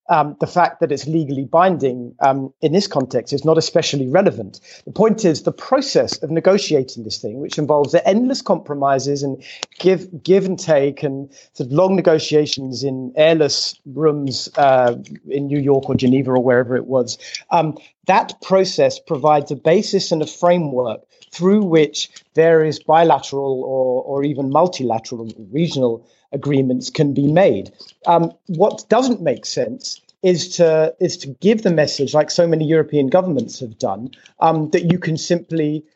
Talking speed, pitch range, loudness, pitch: 165 wpm, 135-170 Hz, -17 LUFS, 150 Hz